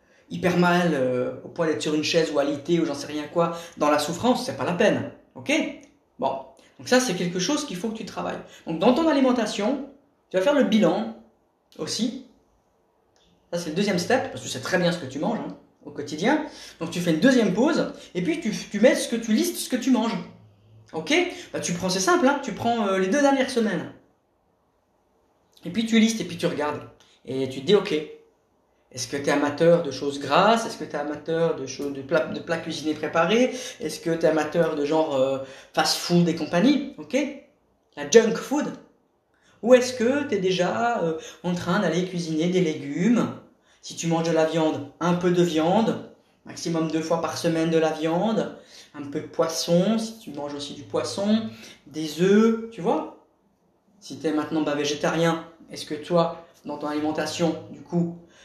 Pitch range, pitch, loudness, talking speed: 155-230 Hz, 175 Hz, -24 LUFS, 210 wpm